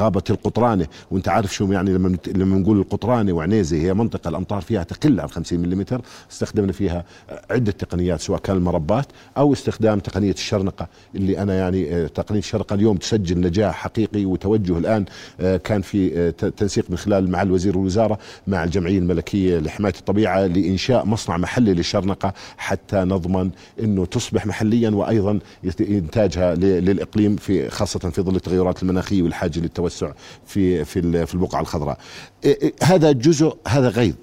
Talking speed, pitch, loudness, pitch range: 150 wpm, 95 Hz, -20 LUFS, 90-105 Hz